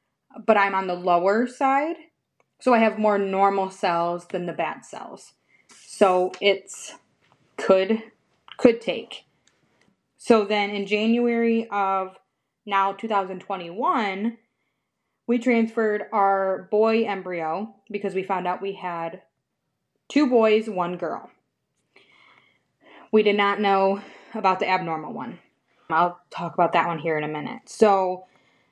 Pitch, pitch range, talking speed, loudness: 200 Hz, 185-220 Hz, 125 wpm, -23 LUFS